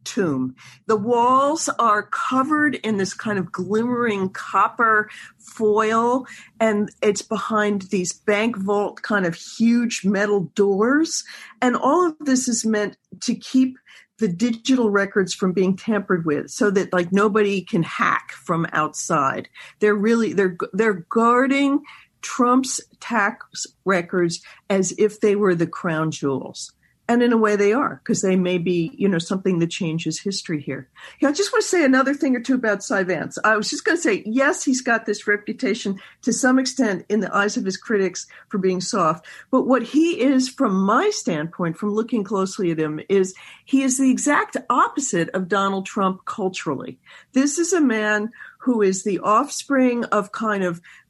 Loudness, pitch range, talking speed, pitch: -21 LUFS, 190-250 Hz, 170 wpm, 210 Hz